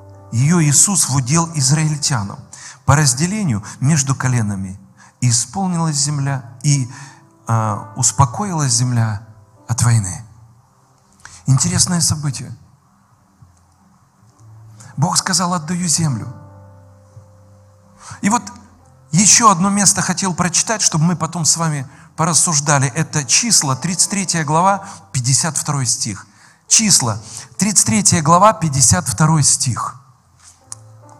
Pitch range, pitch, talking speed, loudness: 110-165 Hz, 140 Hz, 90 wpm, -15 LUFS